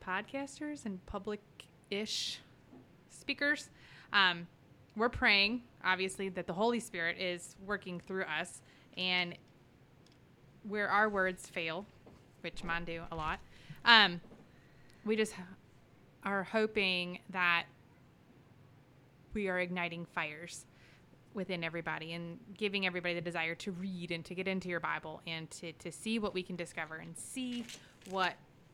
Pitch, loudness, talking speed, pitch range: 180 Hz, -35 LUFS, 135 wpm, 160-200 Hz